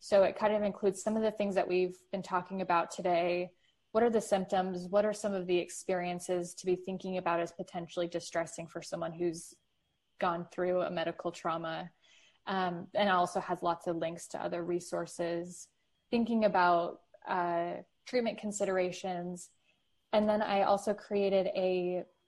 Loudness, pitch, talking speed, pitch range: -33 LUFS, 180 Hz, 165 wpm, 175-200 Hz